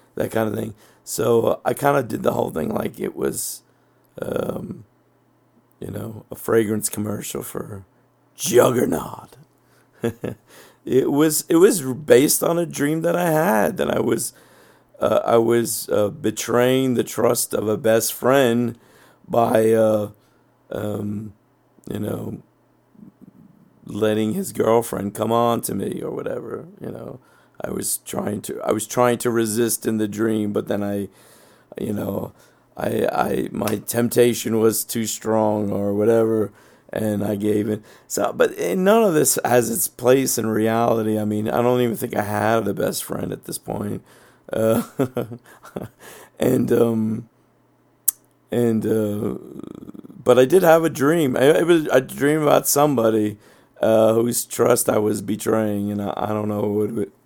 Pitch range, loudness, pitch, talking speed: 105-125 Hz, -20 LUFS, 115 Hz, 155 wpm